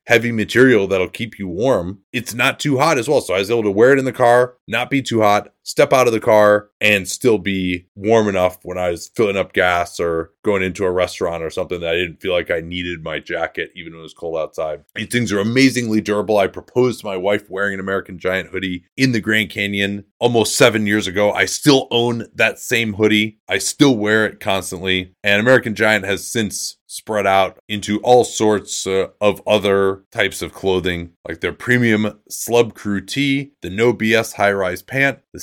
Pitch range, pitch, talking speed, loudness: 95-115 Hz, 105 Hz, 215 wpm, -17 LUFS